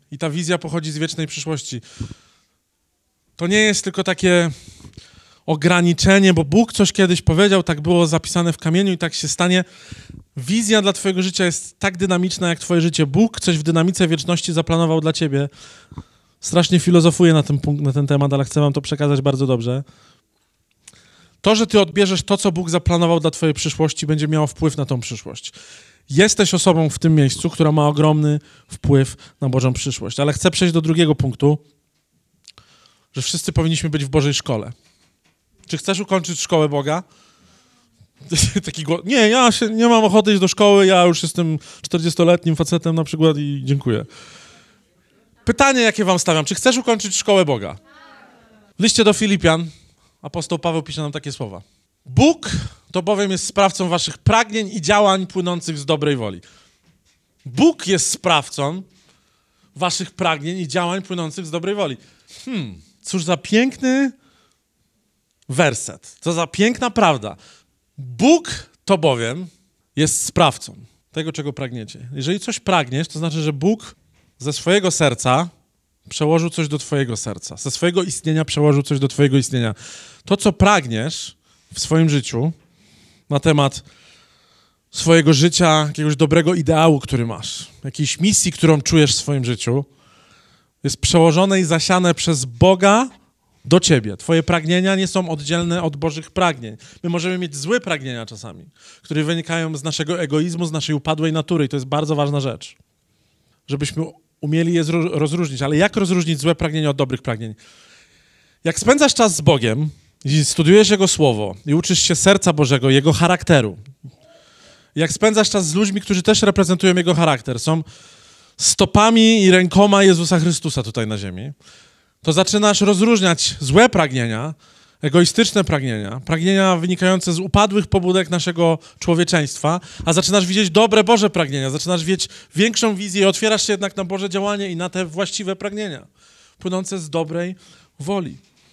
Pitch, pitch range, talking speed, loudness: 165 Hz, 145-190 Hz, 155 wpm, -17 LUFS